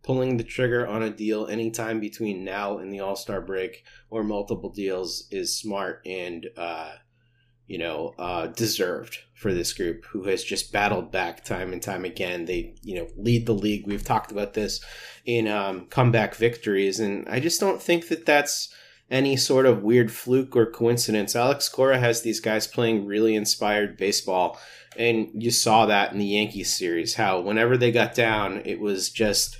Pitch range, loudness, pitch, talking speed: 100-120 Hz, -24 LUFS, 110 Hz, 180 wpm